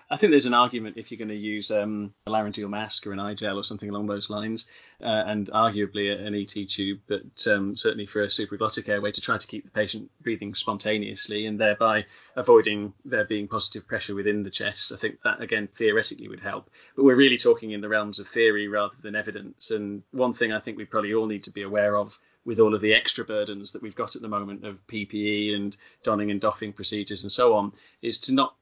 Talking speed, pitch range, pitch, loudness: 235 wpm, 100-110 Hz, 105 Hz, -25 LUFS